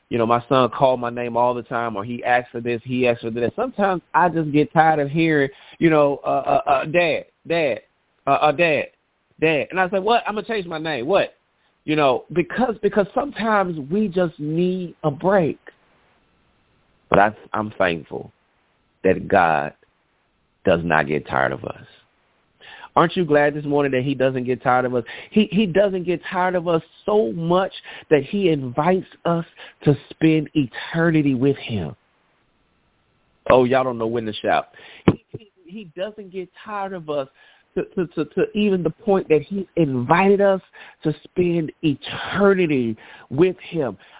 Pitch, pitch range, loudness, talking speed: 155 Hz, 130-185 Hz, -20 LUFS, 180 wpm